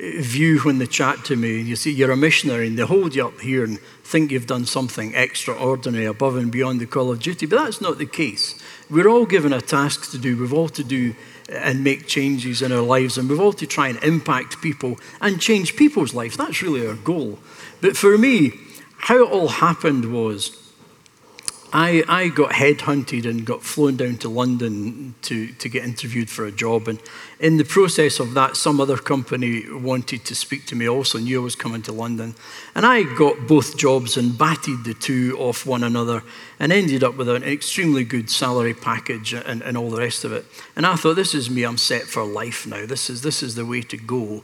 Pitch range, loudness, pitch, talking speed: 120-150 Hz, -20 LUFS, 130 Hz, 220 wpm